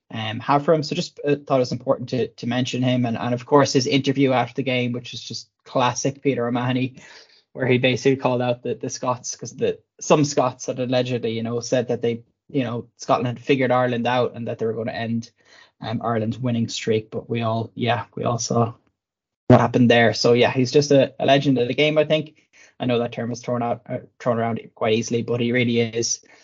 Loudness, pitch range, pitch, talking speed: -21 LUFS, 115-135 Hz, 125 Hz, 240 wpm